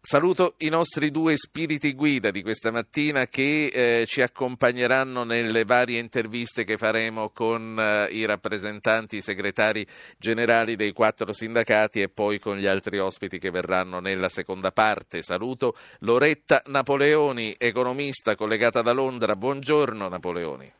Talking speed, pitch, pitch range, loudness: 140 wpm, 115 Hz, 105-135 Hz, -24 LUFS